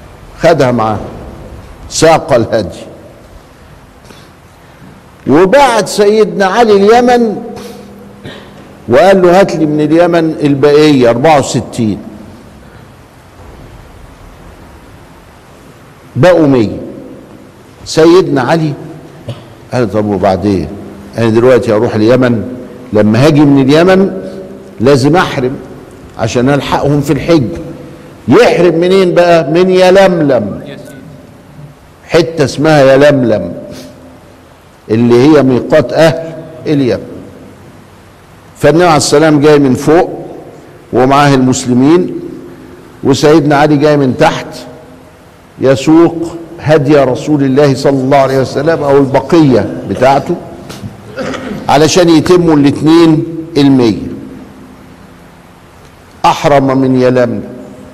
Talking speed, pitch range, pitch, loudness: 85 wpm, 120-165 Hz, 145 Hz, -8 LUFS